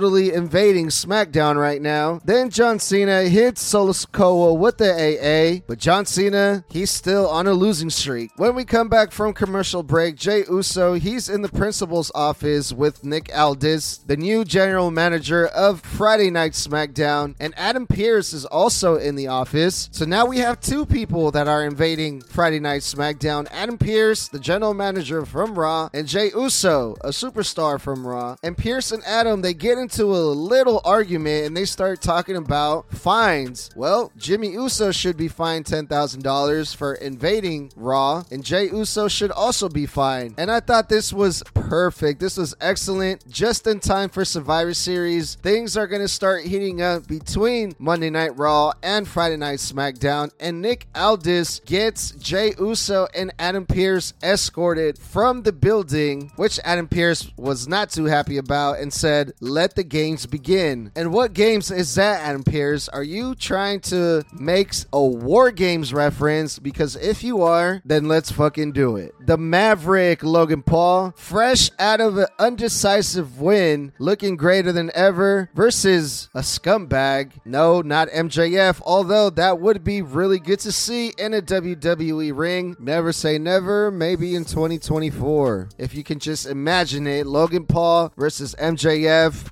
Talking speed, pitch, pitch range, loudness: 165 wpm, 170 Hz, 150-200 Hz, -20 LUFS